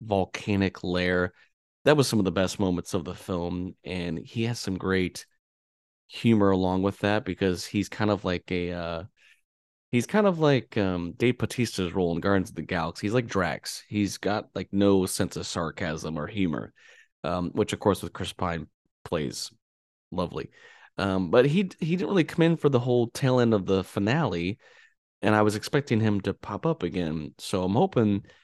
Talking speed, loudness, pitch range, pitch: 190 wpm, -27 LUFS, 90-110 Hz, 95 Hz